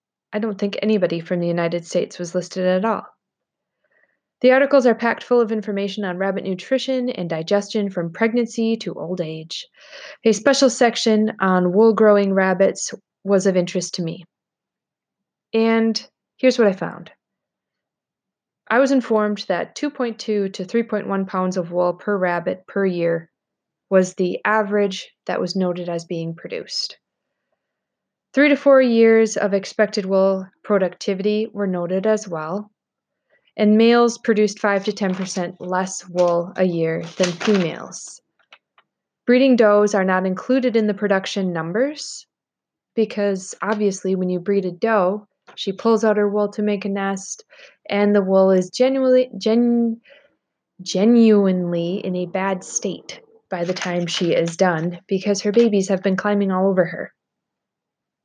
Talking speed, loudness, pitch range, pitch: 150 wpm, -19 LUFS, 185-225 Hz, 200 Hz